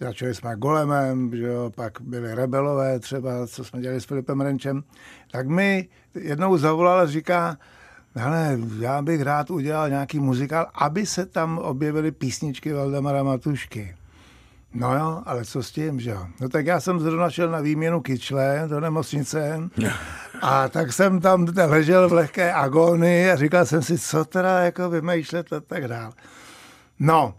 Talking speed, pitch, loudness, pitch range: 160 wpm, 150 Hz, -23 LUFS, 130-165 Hz